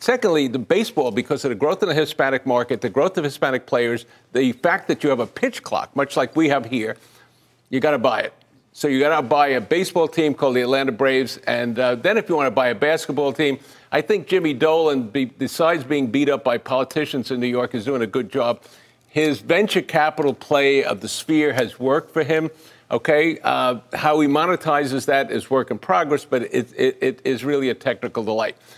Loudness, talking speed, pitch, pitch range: -20 LUFS, 220 wpm, 140 Hz, 130-155 Hz